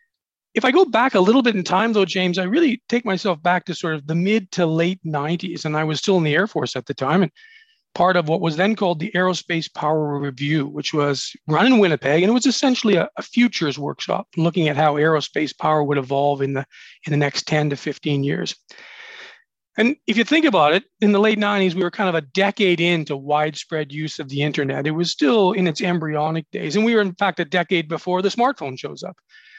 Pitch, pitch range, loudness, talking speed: 175 Hz, 155-210 Hz, -20 LUFS, 235 wpm